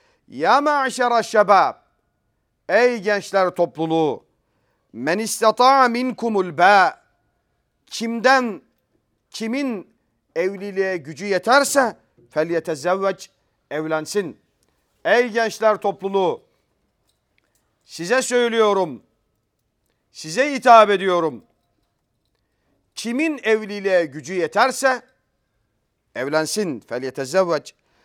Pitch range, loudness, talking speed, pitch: 160-235 Hz, -19 LUFS, 60 wpm, 195 Hz